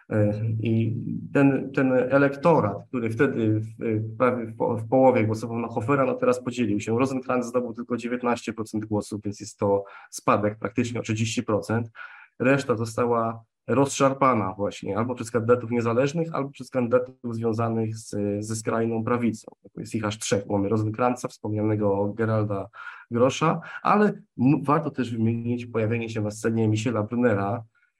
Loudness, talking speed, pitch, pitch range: -25 LUFS, 140 wpm, 115 Hz, 110-125 Hz